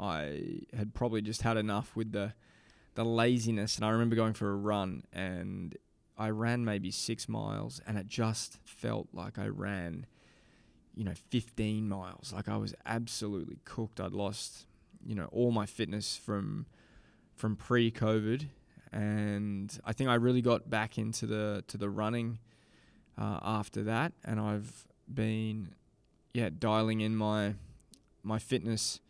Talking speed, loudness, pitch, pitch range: 150 wpm, -35 LUFS, 110 Hz, 105-115 Hz